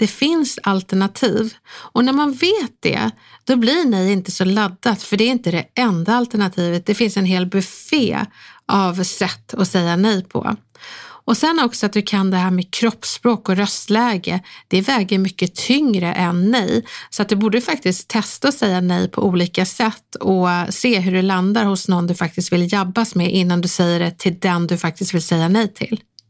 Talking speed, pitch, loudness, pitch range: 195 wpm, 195 Hz, -18 LUFS, 180-230 Hz